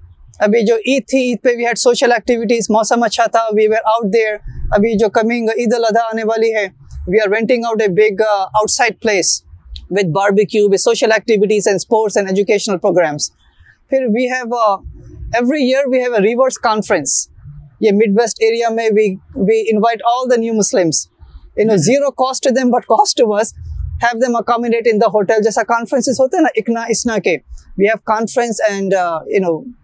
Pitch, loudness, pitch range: 225 Hz, -14 LUFS, 210-240 Hz